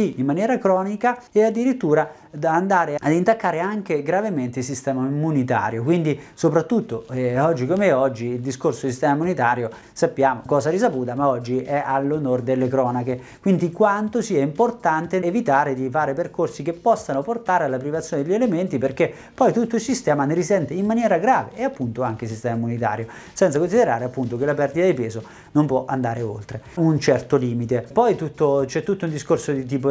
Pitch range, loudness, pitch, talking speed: 130-180 Hz, -21 LUFS, 145 Hz, 175 wpm